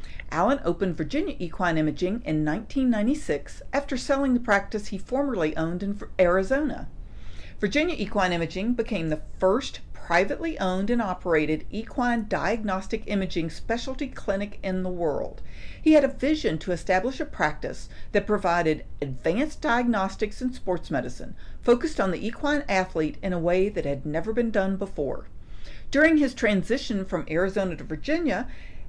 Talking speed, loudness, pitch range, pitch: 145 wpm, -26 LUFS, 180-250 Hz, 200 Hz